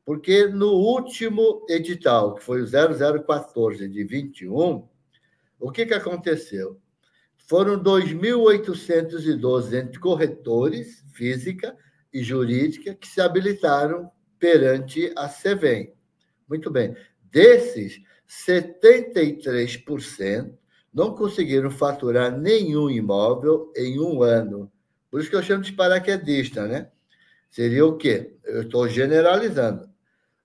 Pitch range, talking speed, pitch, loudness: 130-185 Hz, 100 wpm, 155 Hz, -21 LUFS